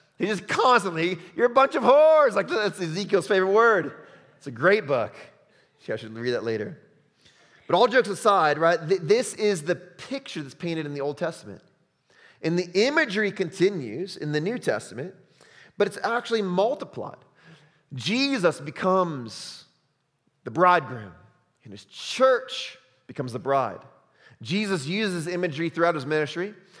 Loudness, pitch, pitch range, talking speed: -24 LUFS, 180 Hz, 150-205 Hz, 150 wpm